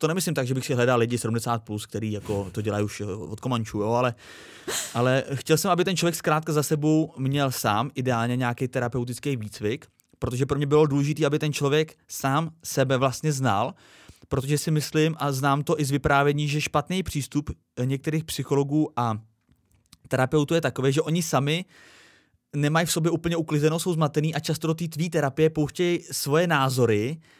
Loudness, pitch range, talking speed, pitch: -25 LUFS, 125-155 Hz, 180 wpm, 140 Hz